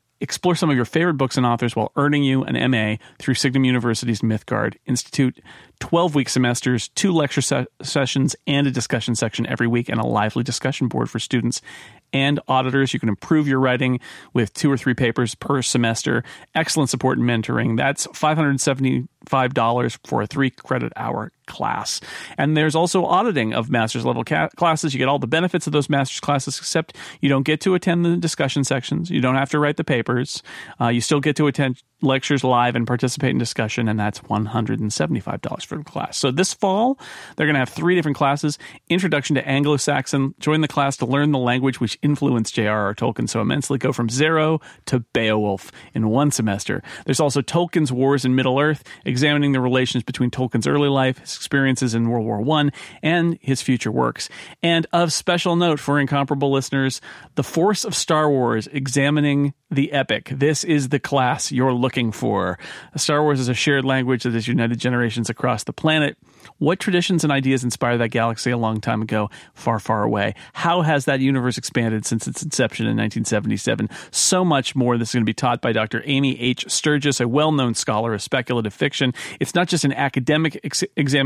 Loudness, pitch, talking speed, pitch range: -20 LUFS, 135 Hz, 190 wpm, 120-150 Hz